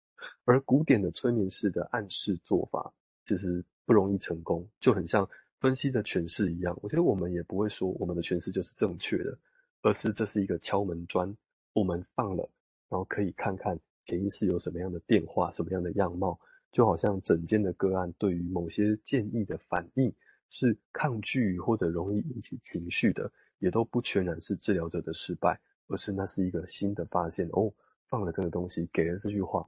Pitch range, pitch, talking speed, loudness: 90-110 Hz, 95 Hz, 300 characters per minute, -31 LUFS